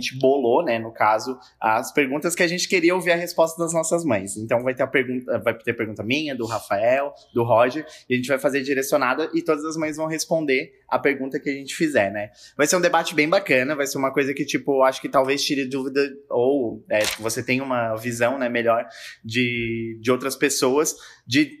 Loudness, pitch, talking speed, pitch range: -22 LUFS, 135 Hz, 220 wpm, 120-155 Hz